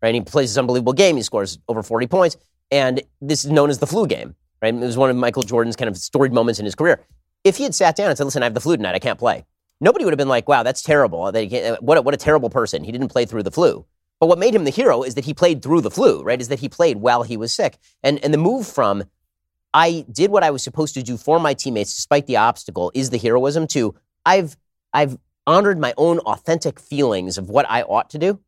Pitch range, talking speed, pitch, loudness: 115-155 Hz, 270 wpm, 135 Hz, -18 LUFS